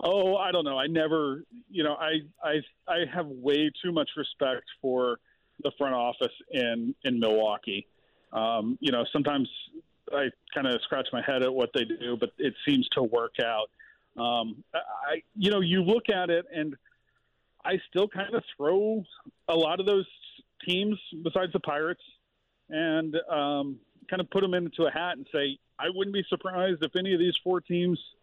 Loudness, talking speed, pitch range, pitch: -29 LUFS, 185 wpm, 140-190 Hz, 165 Hz